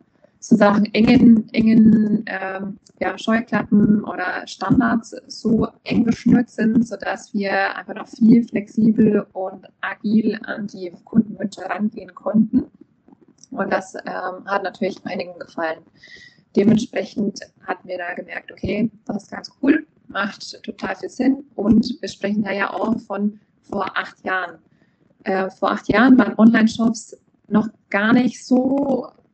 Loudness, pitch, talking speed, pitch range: -19 LUFS, 215 Hz, 135 wpm, 195-235 Hz